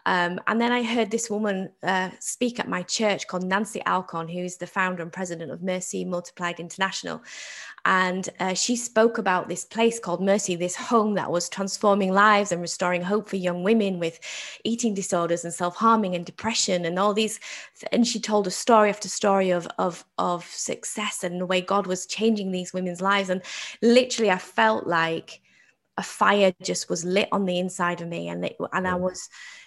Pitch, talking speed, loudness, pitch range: 190 Hz, 195 wpm, -24 LUFS, 180-210 Hz